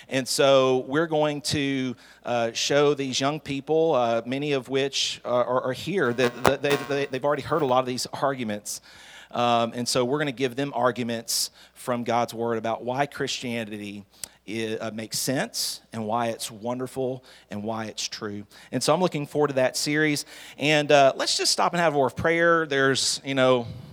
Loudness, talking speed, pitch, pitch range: -24 LUFS, 200 wpm, 130 Hz, 120-145 Hz